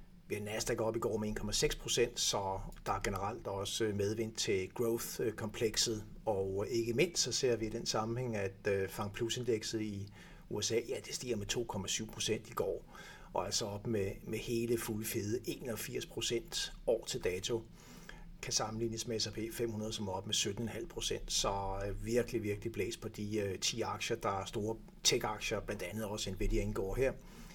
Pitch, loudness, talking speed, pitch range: 110 Hz, -37 LUFS, 170 wpm, 105-115 Hz